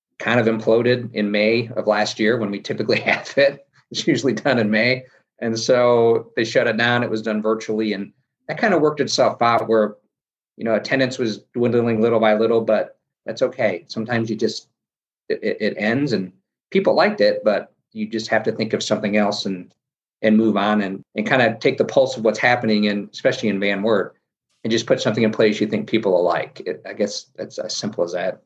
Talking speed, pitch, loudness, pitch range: 220 wpm, 110 Hz, -20 LUFS, 105-120 Hz